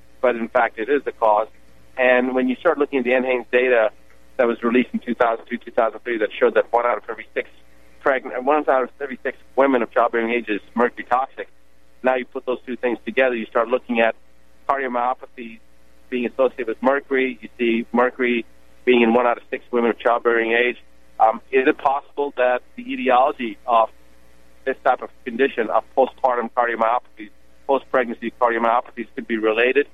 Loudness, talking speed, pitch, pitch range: -20 LUFS, 180 wpm, 120 Hz, 105-130 Hz